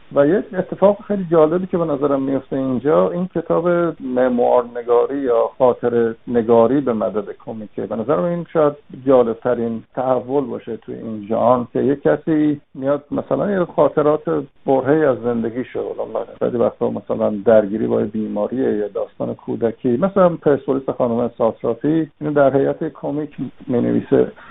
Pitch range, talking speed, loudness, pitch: 120-155 Hz, 145 wpm, -18 LUFS, 135 Hz